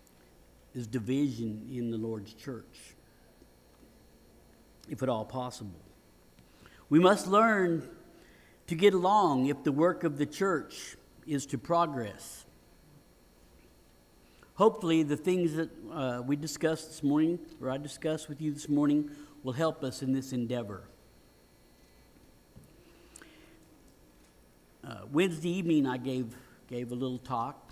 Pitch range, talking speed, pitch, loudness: 110-160 Hz, 120 wpm, 130 Hz, -30 LUFS